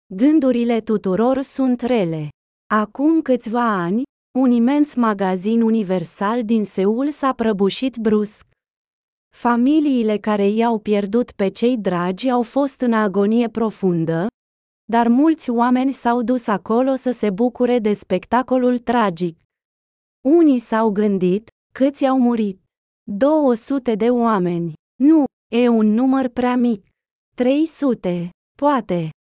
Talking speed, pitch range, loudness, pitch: 115 wpm, 210-255 Hz, -18 LUFS, 235 Hz